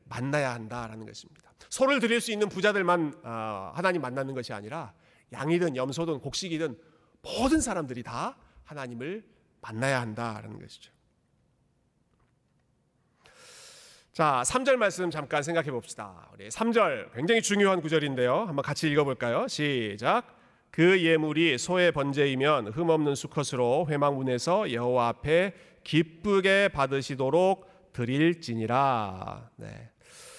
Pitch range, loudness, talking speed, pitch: 125-175 Hz, -27 LUFS, 285 characters per minute, 150 Hz